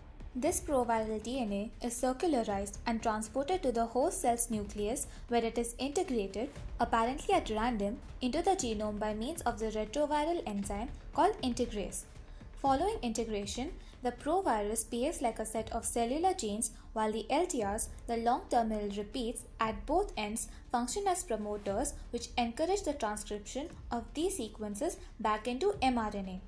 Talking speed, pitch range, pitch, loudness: 145 wpm, 215-270 Hz, 235 Hz, -34 LUFS